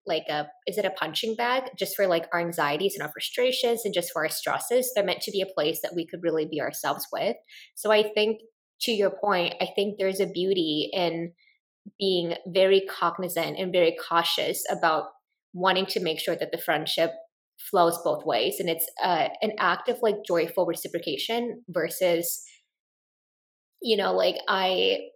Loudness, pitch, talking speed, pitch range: -26 LUFS, 190 Hz, 180 wpm, 170-215 Hz